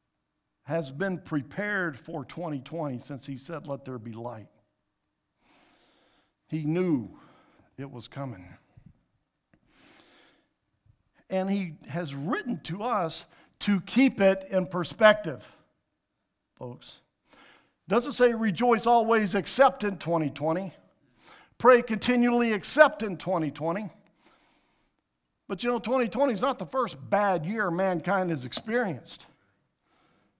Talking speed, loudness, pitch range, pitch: 105 wpm, -27 LUFS, 155-230 Hz, 190 Hz